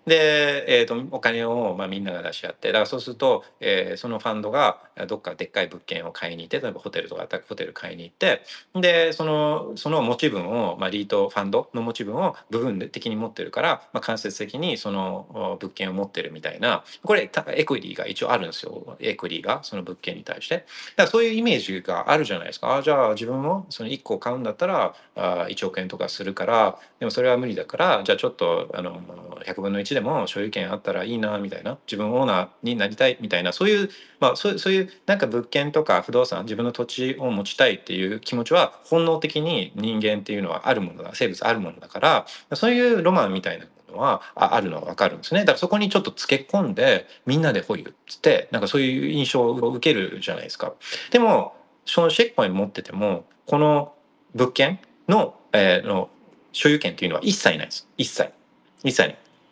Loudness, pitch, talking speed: -23 LUFS, 155 Hz, 445 characters per minute